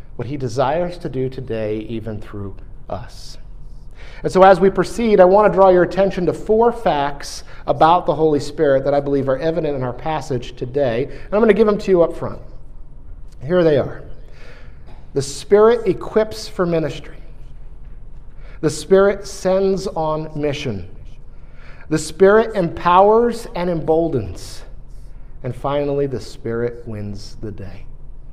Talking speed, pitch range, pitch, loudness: 150 wpm, 125-185 Hz, 155 Hz, -17 LUFS